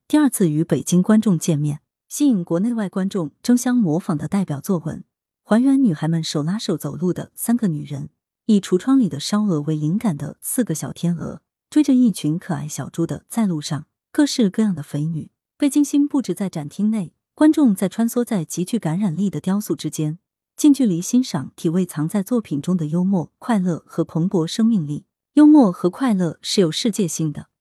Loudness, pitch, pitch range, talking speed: -20 LUFS, 185 Hz, 160-230 Hz, 295 characters per minute